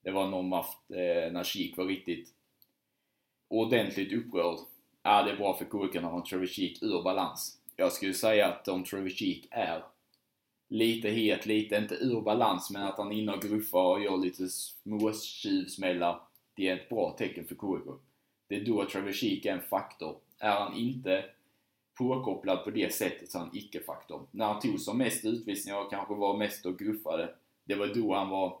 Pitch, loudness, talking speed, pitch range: 100 Hz, -32 LUFS, 180 wpm, 95-110 Hz